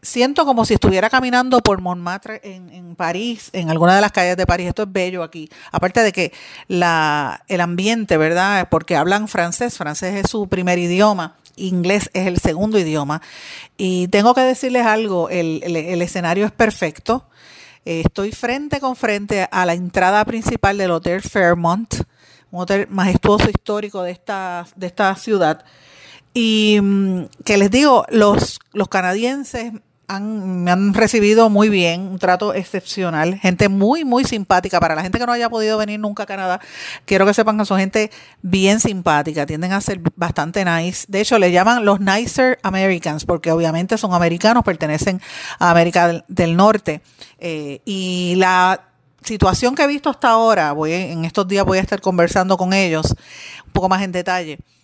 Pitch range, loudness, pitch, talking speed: 175-215 Hz, -17 LUFS, 190 Hz, 170 wpm